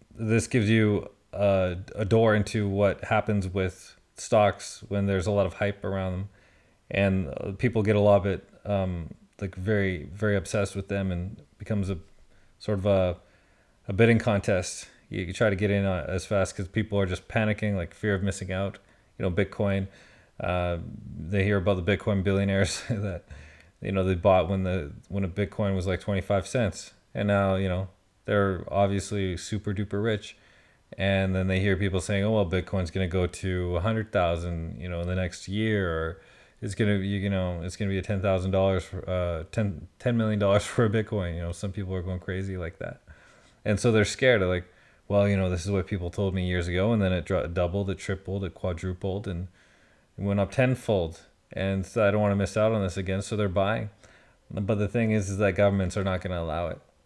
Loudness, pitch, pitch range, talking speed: -27 LUFS, 100 Hz, 95-105 Hz, 210 wpm